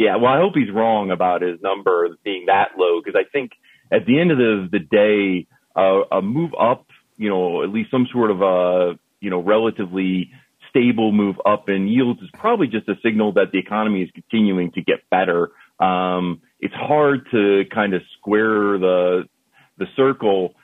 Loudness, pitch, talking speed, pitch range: -19 LUFS, 100 Hz, 190 wpm, 90-110 Hz